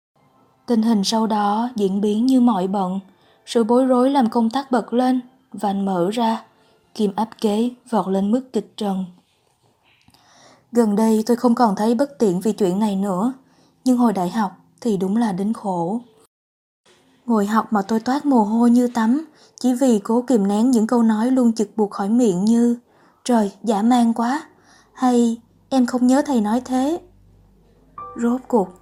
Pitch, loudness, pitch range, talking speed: 230 Hz, -19 LUFS, 210-245 Hz, 180 wpm